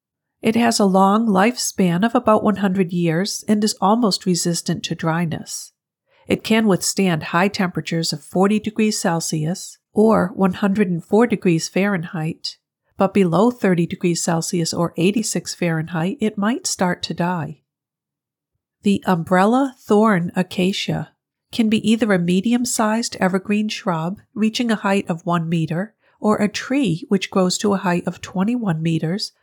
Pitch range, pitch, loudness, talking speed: 175-215 Hz, 190 Hz, -19 LUFS, 145 wpm